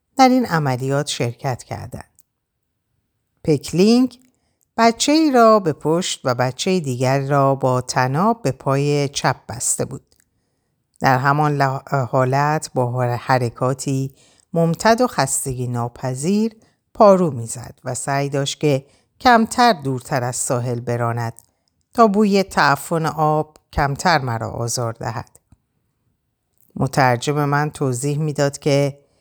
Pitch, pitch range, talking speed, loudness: 140 Hz, 125-155 Hz, 110 wpm, -18 LUFS